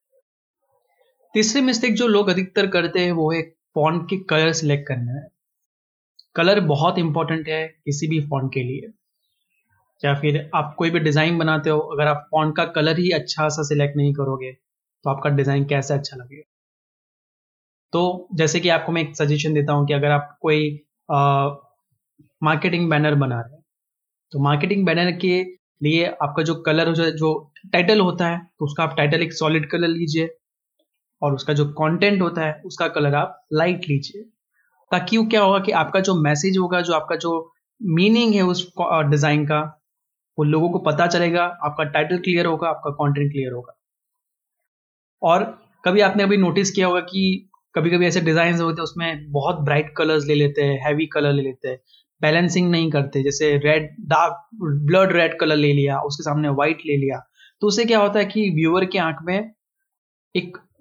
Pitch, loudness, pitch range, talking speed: 160 Hz, -20 LUFS, 150-180 Hz, 180 wpm